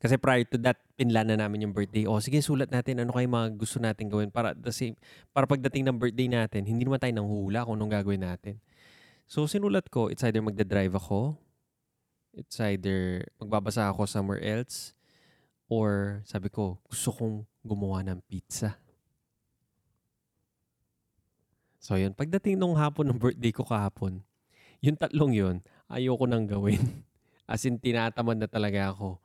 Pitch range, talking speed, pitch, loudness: 105-125 Hz, 160 wpm, 110 Hz, -29 LUFS